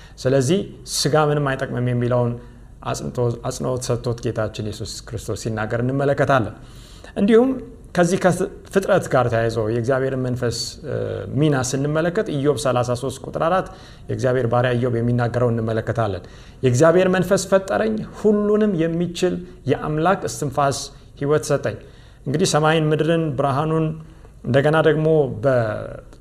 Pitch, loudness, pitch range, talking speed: 135 Hz, -20 LUFS, 120-160 Hz, 105 wpm